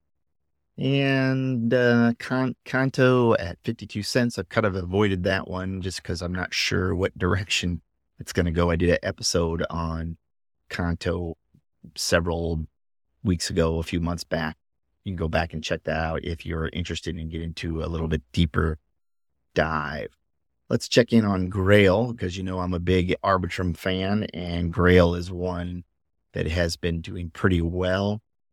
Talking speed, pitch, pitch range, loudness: 165 wpm, 90 Hz, 80-95 Hz, -25 LUFS